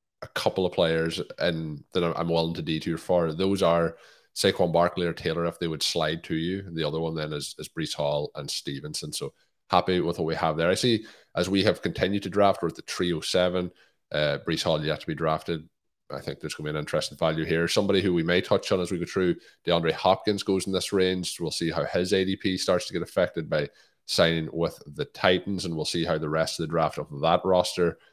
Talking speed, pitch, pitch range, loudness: 235 wpm, 85 Hz, 80-90 Hz, -26 LUFS